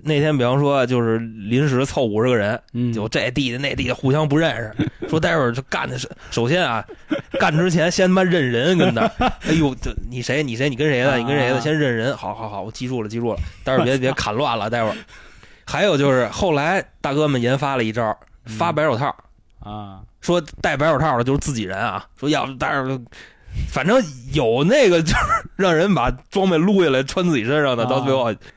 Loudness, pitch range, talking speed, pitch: -19 LUFS, 120-155 Hz, 305 characters per minute, 135 Hz